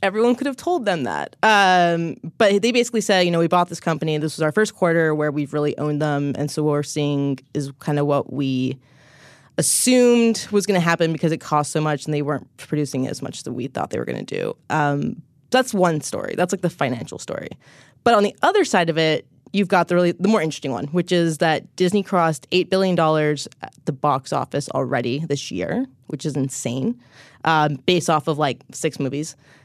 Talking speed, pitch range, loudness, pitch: 225 wpm, 145-180 Hz, -21 LUFS, 155 Hz